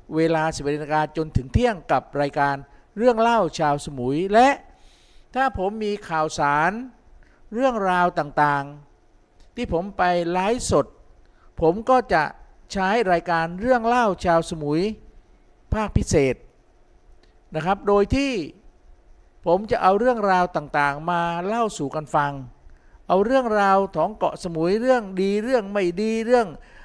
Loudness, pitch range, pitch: -22 LUFS, 155-220 Hz, 180 Hz